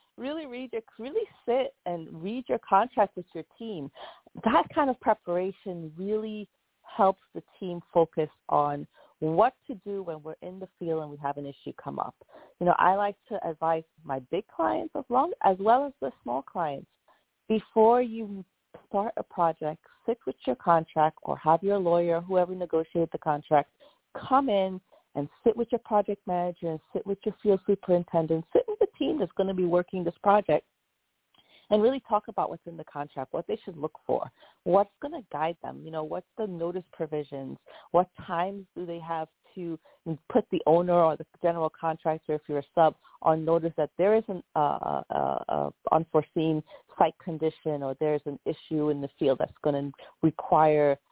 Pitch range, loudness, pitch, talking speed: 160-210 Hz, -28 LUFS, 175 Hz, 190 wpm